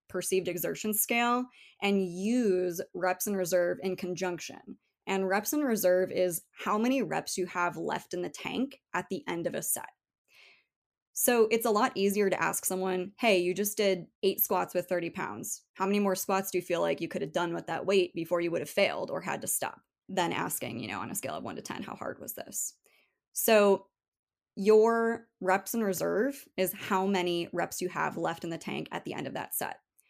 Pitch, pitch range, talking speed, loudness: 190 Hz, 180-215 Hz, 215 wpm, -30 LUFS